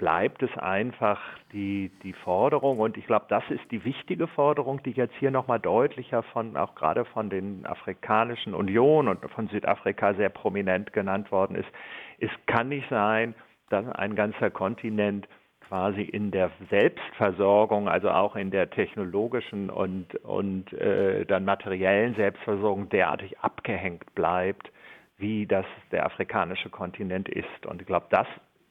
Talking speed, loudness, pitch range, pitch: 150 wpm, -27 LUFS, 100-120 Hz, 105 Hz